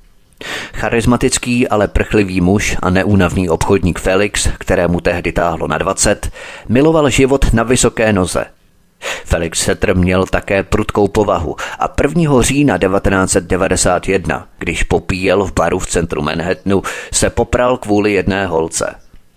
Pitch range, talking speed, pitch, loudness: 95-115 Hz, 125 wpm, 100 Hz, -14 LUFS